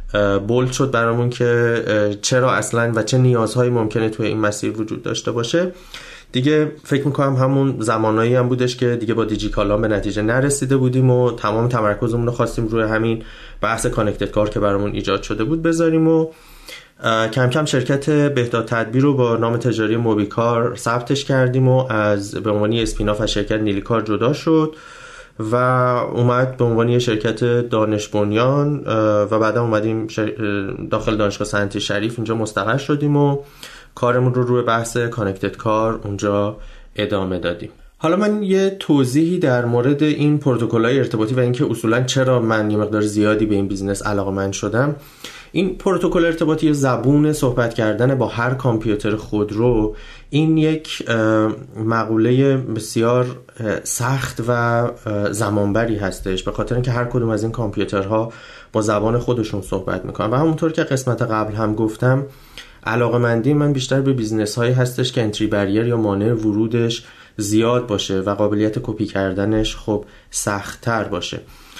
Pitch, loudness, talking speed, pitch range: 115 Hz, -18 LUFS, 155 wpm, 105-130 Hz